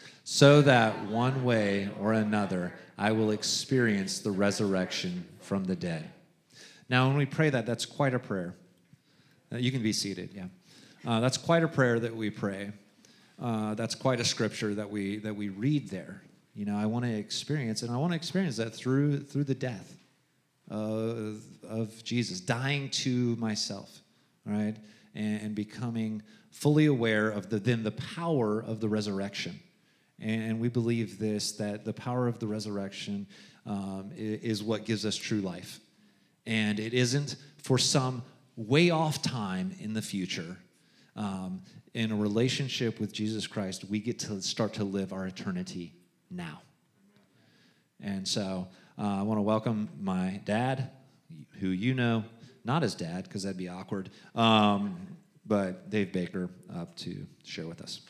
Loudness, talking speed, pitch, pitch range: -30 LUFS, 160 wpm, 110 Hz, 105-130 Hz